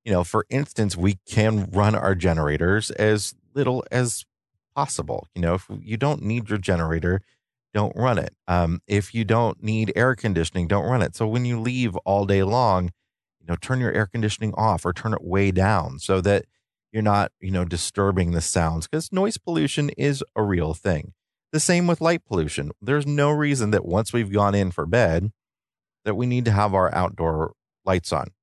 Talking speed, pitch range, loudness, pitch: 195 wpm, 90-120 Hz, -23 LUFS, 105 Hz